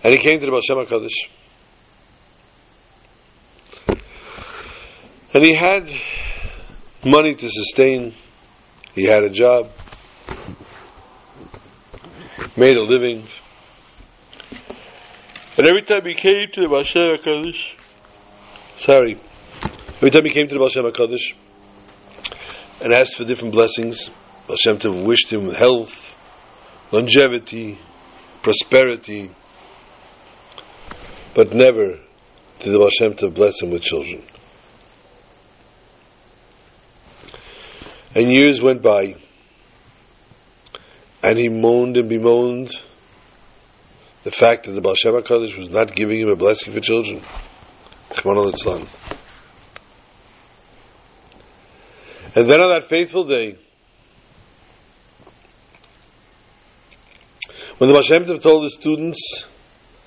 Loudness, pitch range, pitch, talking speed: -16 LUFS, 105-150 Hz, 120 Hz, 95 wpm